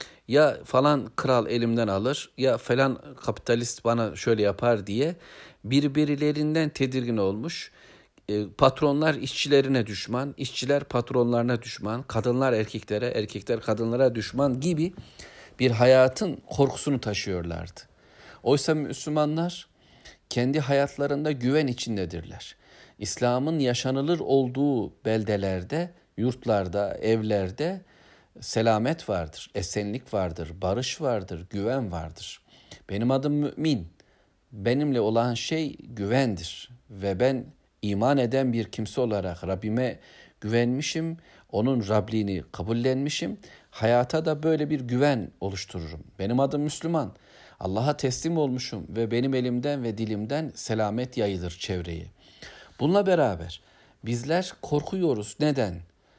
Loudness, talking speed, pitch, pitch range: -26 LUFS, 100 wpm, 125 Hz, 105-140 Hz